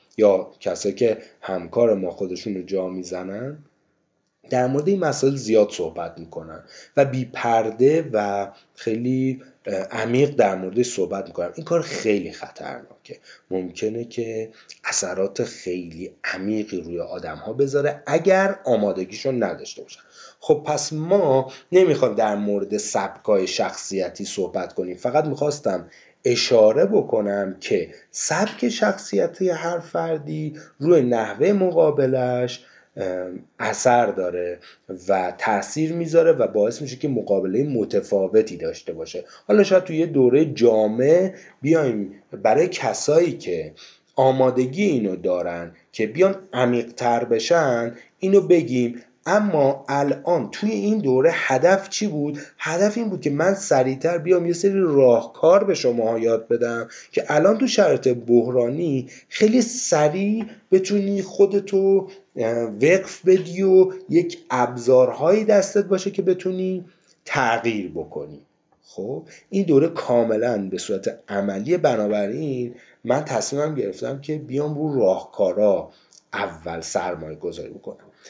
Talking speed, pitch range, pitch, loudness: 120 wpm, 115-190 Hz, 140 Hz, -21 LUFS